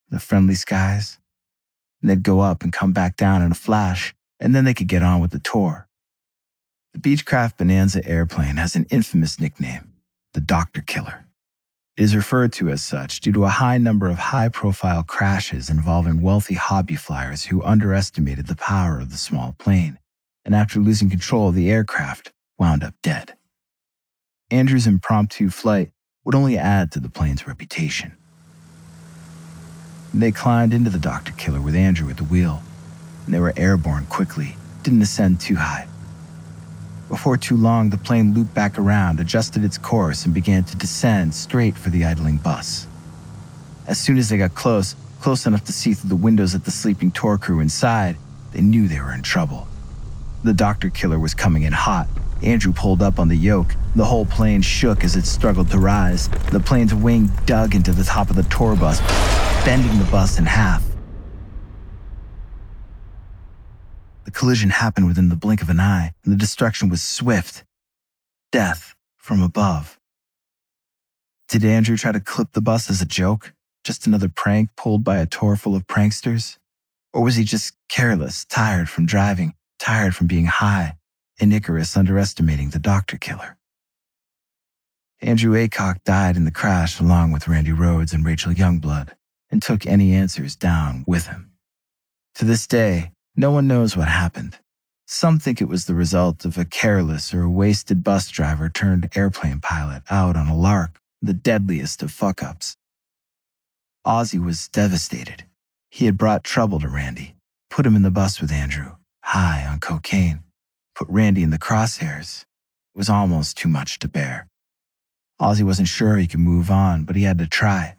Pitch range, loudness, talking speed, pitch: 80-105 Hz, -19 LUFS, 170 wpm, 95 Hz